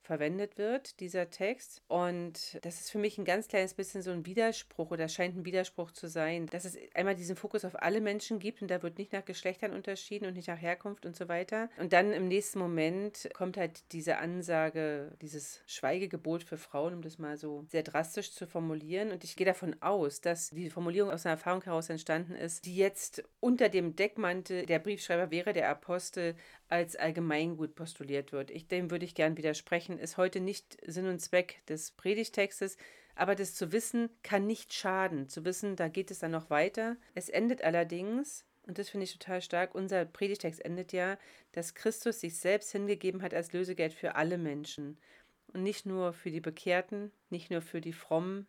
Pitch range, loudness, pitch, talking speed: 165-200 Hz, -35 LUFS, 180 Hz, 195 wpm